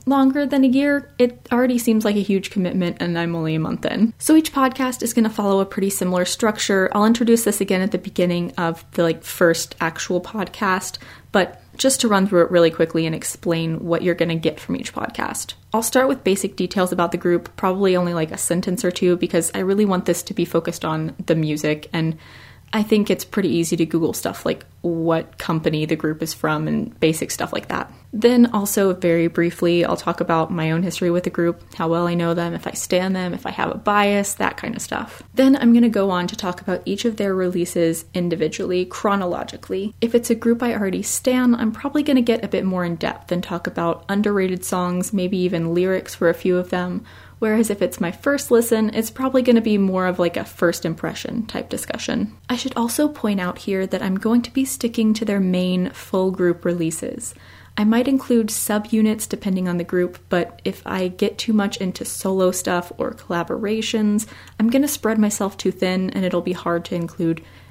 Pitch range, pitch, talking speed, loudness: 170-220 Hz, 185 Hz, 220 wpm, -20 LUFS